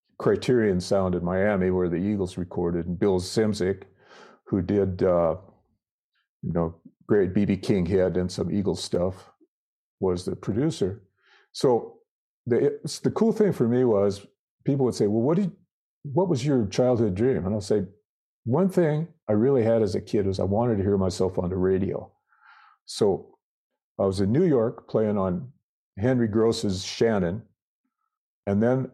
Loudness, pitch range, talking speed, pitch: -25 LUFS, 95-135 Hz, 165 wpm, 105 Hz